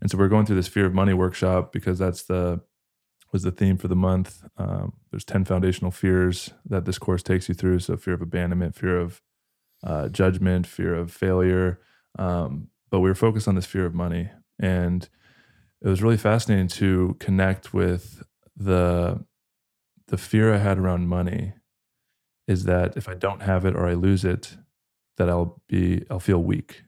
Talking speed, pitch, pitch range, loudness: 185 wpm, 95 Hz, 90-95 Hz, -24 LUFS